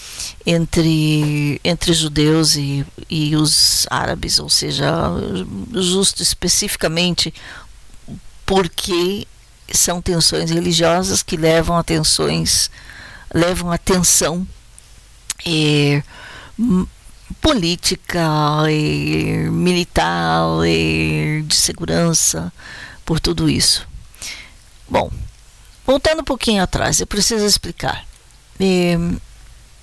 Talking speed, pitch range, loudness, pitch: 85 wpm, 125-180 Hz, -16 LUFS, 165 Hz